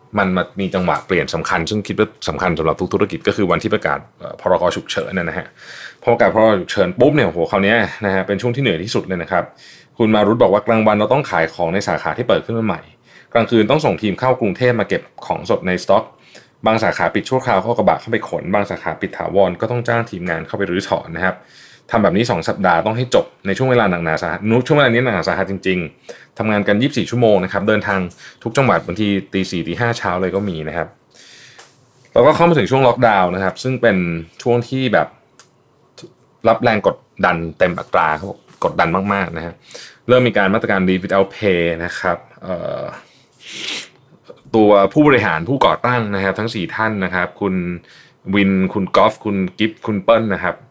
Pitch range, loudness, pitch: 95-115 Hz, -17 LUFS, 100 Hz